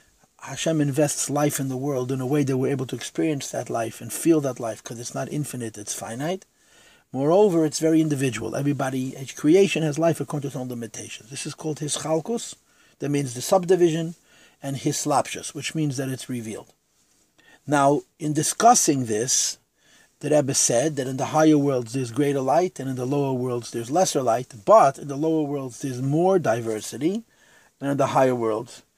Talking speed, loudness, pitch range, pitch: 195 wpm, -23 LUFS, 130-155 Hz, 140 Hz